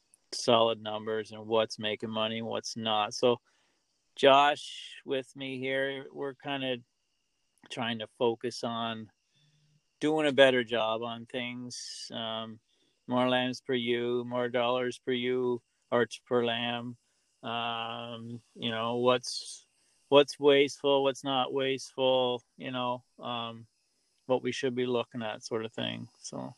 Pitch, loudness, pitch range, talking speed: 120 Hz, -30 LUFS, 115-130 Hz, 140 wpm